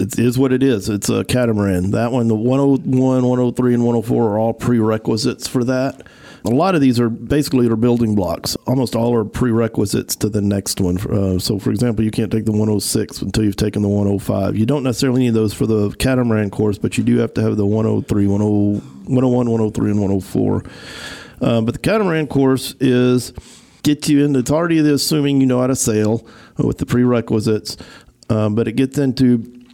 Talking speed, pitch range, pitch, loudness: 200 wpm, 105-130 Hz, 115 Hz, -17 LUFS